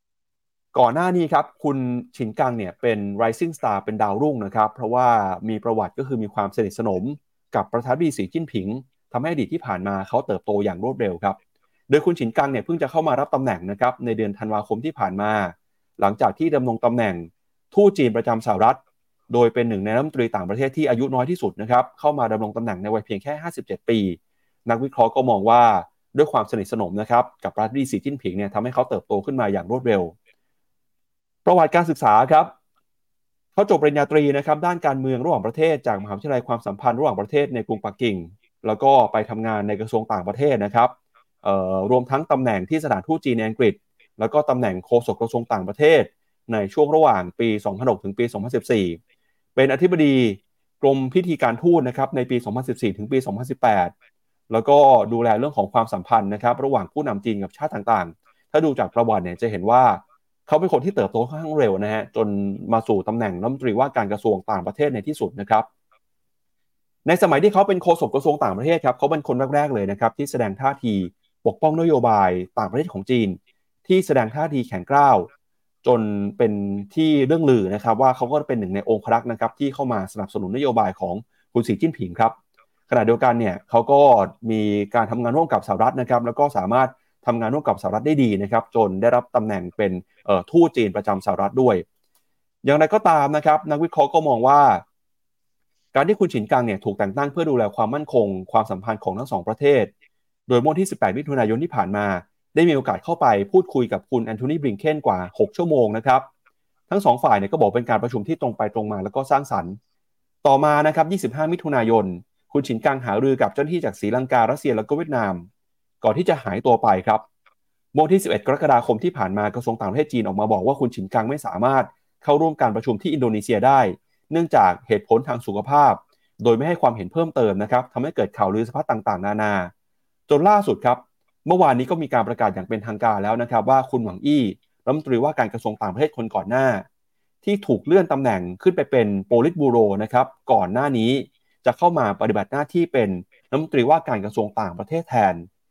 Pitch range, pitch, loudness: 105-145 Hz, 120 Hz, -20 LUFS